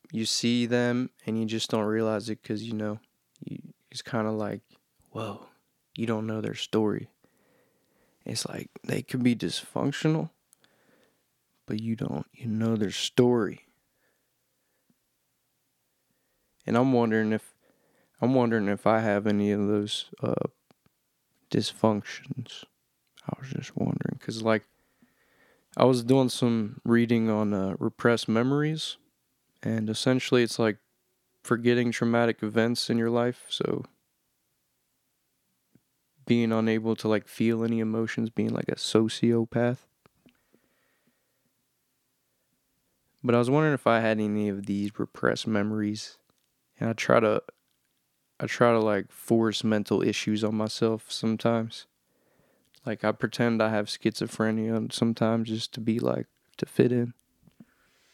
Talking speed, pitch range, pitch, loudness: 130 wpm, 110-120 Hz, 115 Hz, -27 LUFS